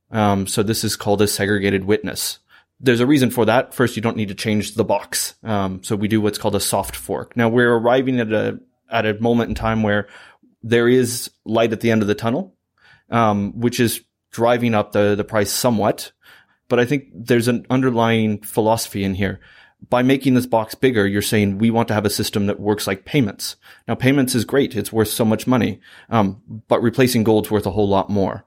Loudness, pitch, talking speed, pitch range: -19 LUFS, 110 Hz, 235 wpm, 105-120 Hz